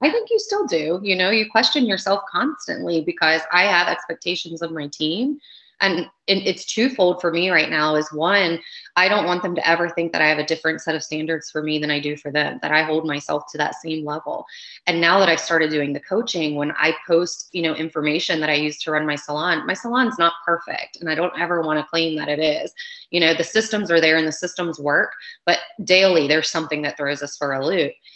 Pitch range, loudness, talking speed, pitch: 155-185 Hz, -20 LUFS, 240 wpm, 165 Hz